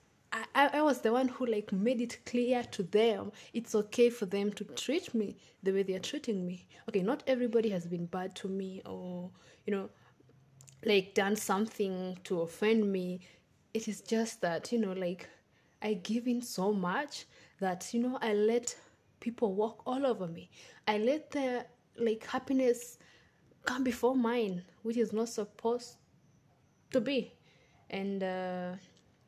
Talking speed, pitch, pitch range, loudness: 165 wpm, 215 Hz, 185-240 Hz, -34 LUFS